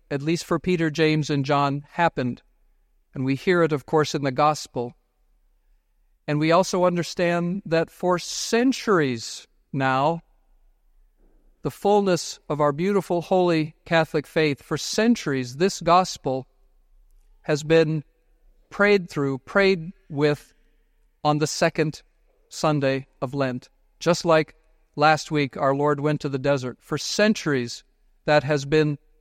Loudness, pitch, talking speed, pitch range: -23 LUFS, 155 Hz, 130 wpm, 140-170 Hz